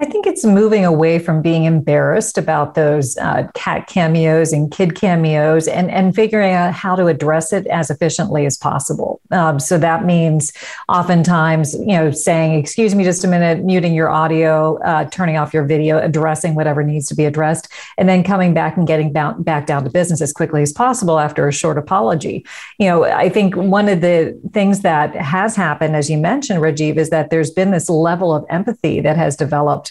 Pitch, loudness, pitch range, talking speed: 165 Hz, -15 LUFS, 155-185 Hz, 200 wpm